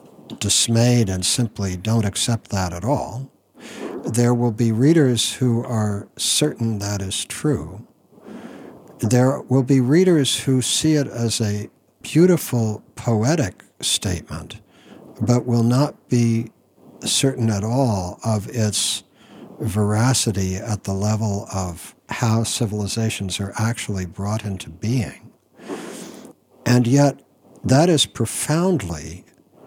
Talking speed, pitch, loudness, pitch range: 115 wpm, 115 Hz, -20 LUFS, 105-130 Hz